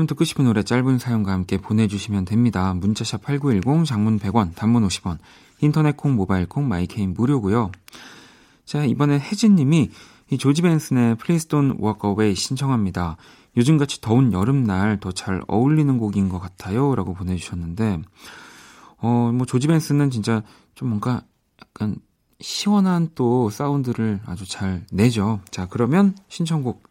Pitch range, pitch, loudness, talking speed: 100-140 Hz, 115 Hz, -21 LUFS, 305 characters per minute